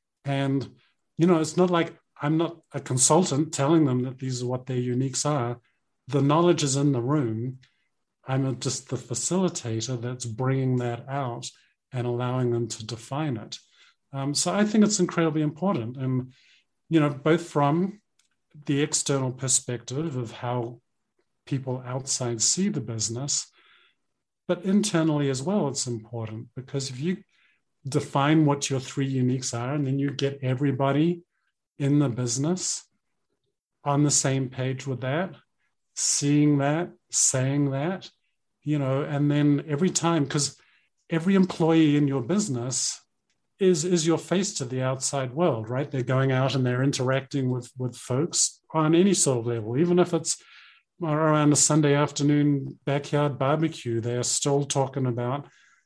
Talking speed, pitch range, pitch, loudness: 155 wpm, 130-160 Hz, 140 Hz, -25 LUFS